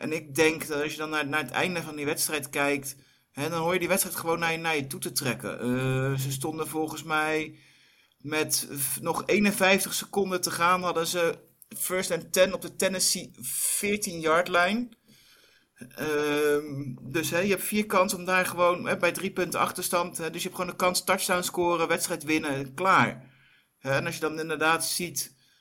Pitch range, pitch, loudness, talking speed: 150-185 Hz, 165 Hz, -27 LUFS, 190 wpm